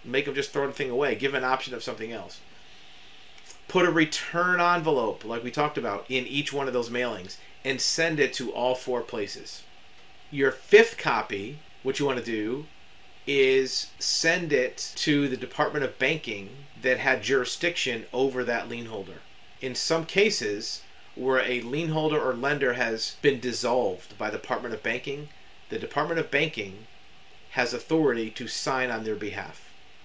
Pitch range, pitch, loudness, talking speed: 125-150 Hz, 135 Hz, -26 LUFS, 170 wpm